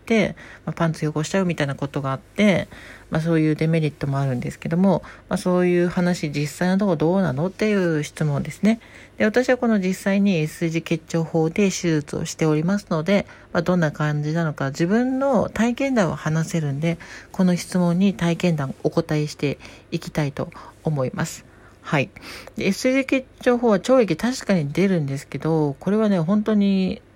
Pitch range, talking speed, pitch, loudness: 155-195 Hz, 355 characters per minute, 170 Hz, -22 LUFS